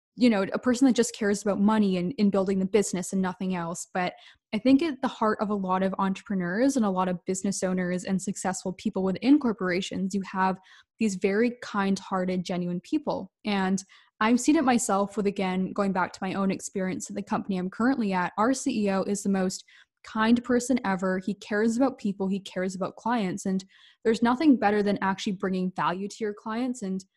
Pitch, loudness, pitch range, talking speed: 200 Hz, -27 LUFS, 190-225 Hz, 205 wpm